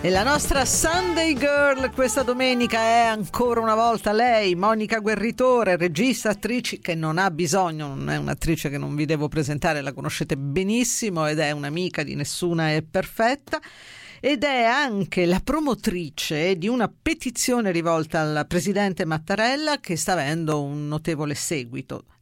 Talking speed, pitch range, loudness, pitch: 150 wpm, 160-240 Hz, -23 LUFS, 195 Hz